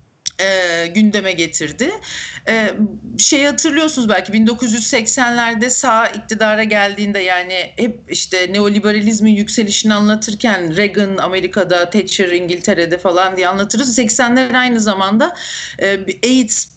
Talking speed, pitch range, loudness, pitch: 105 wpm, 190-235 Hz, -12 LUFS, 210 Hz